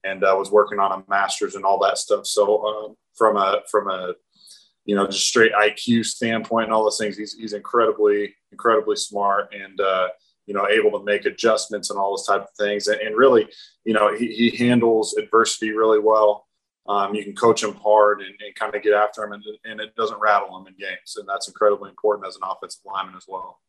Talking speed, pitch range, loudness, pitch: 225 wpm, 100-115 Hz, -20 LUFS, 105 Hz